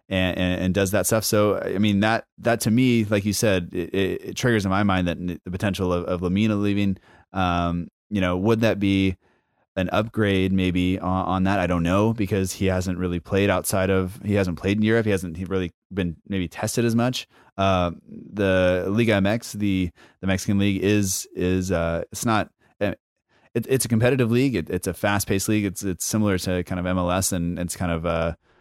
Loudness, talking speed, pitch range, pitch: -23 LUFS, 210 wpm, 90-105 Hz, 95 Hz